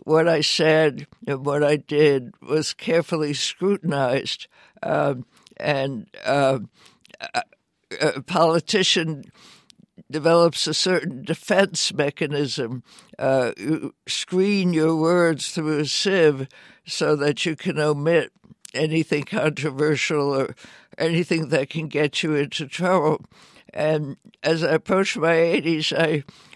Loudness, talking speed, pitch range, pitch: -22 LUFS, 115 wpm, 145-170 Hz, 155 Hz